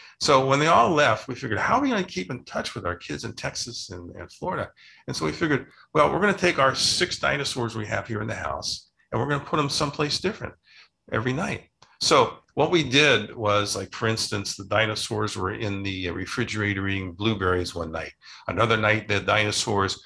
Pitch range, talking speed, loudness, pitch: 100-135 Hz, 210 wpm, -24 LUFS, 110 Hz